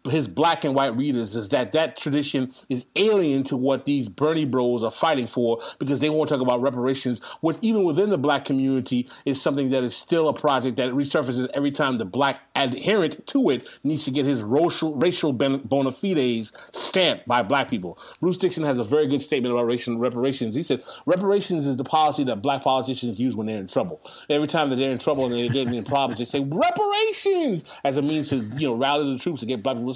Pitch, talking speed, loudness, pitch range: 140 Hz, 220 wpm, -23 LUFS, 125-155 Hz